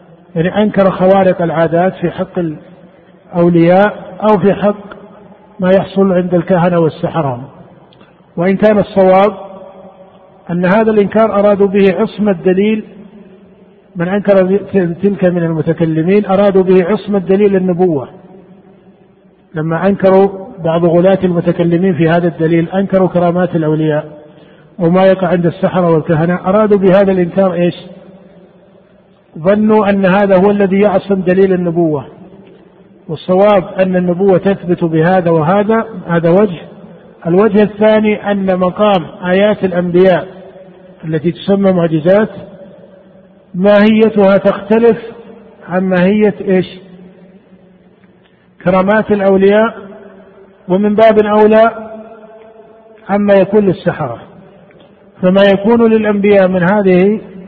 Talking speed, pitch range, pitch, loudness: 100 wpm, 180-200 Hz, 190 Hz, -11 LUFS